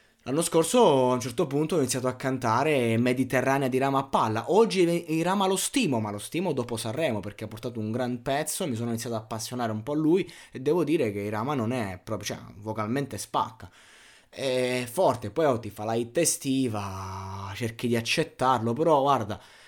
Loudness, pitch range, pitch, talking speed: -27 LUFS, 110-140 Hz, 125 Hz, 200 wpm